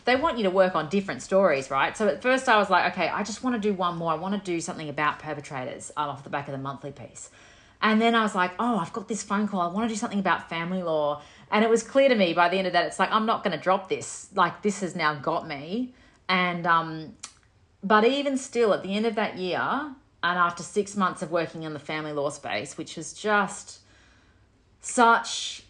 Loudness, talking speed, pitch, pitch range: -25 LUFS, 250 wpm, 185 Hz, 160-215 Hz